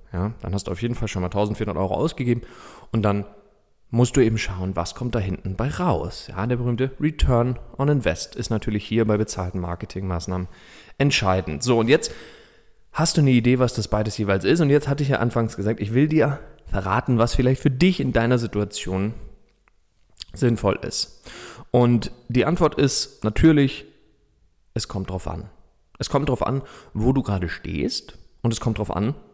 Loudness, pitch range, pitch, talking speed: -22 LUFS, 100-130 Hz, 115 Hz, 185 wpm